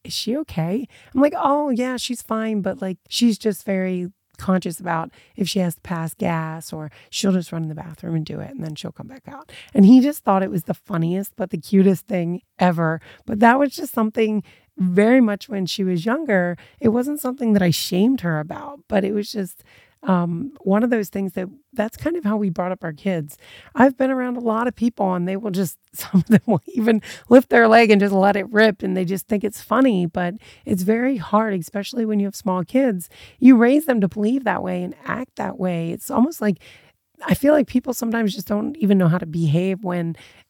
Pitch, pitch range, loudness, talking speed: 200 Hz, 180-235 Hz, -20 LUFS, 230 wpm